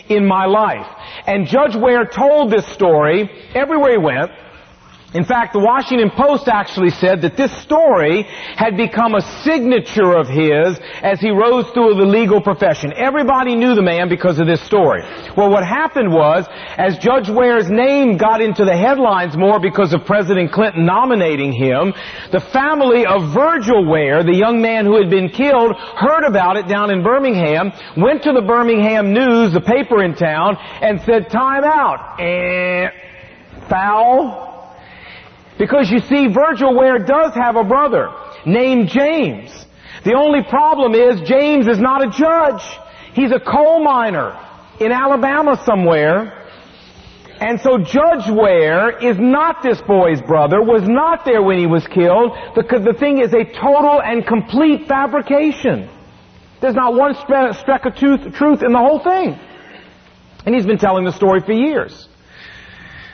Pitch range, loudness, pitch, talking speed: 195-270 Hz, -14 LUFS, 230 Hz, 160 wpm